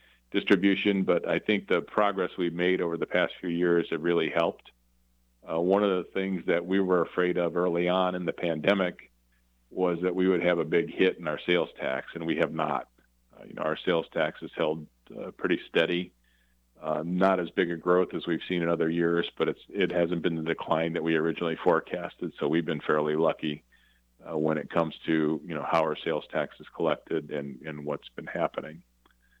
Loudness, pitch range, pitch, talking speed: -28 LUFS, 75-90 Hz, 85 Hz, 210 wpm